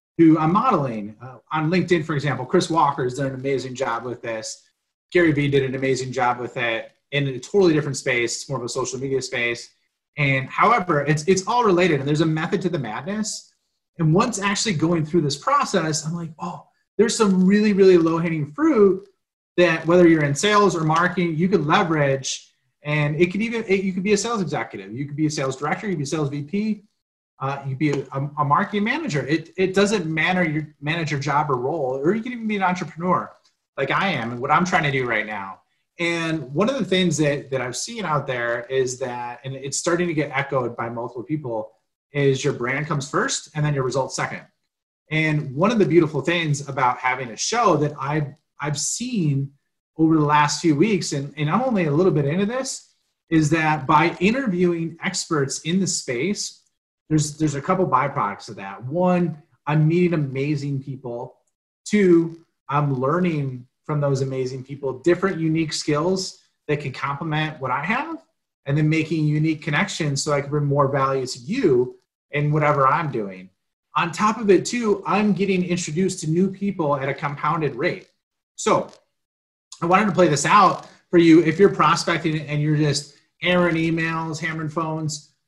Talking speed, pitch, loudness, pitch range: 200 wpm, 155 Hz, -21 LUFS, 140-180 Hz